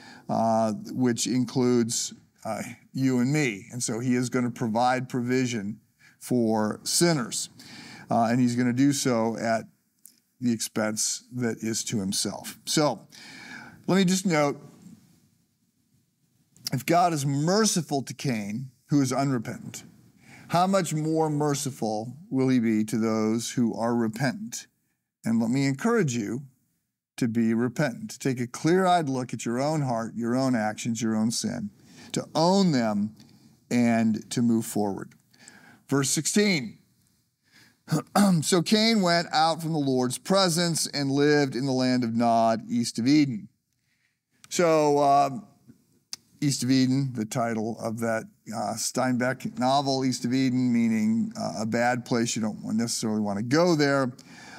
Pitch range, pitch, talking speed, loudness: 115-150 Hz, 130 Hz, 150 wpm, -25 LUFS